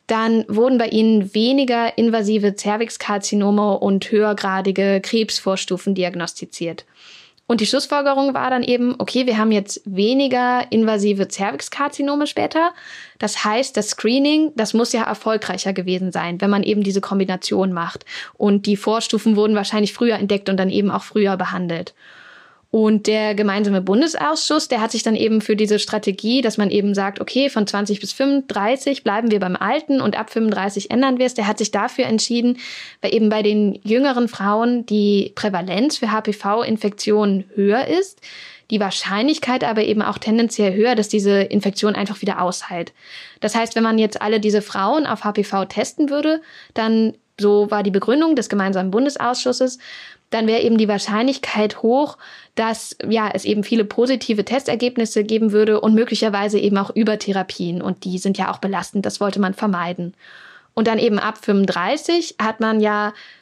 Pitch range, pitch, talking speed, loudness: 200-235 Hz, 215 Hz, 165 wpm, -19 LUFS